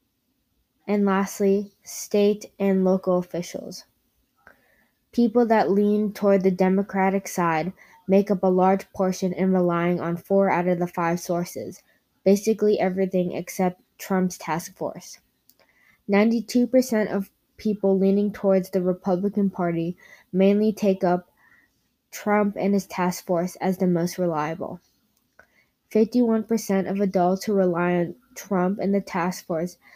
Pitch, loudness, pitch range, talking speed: 190 Hz, -23 LUFS, 180-205 Hz, 130 wpm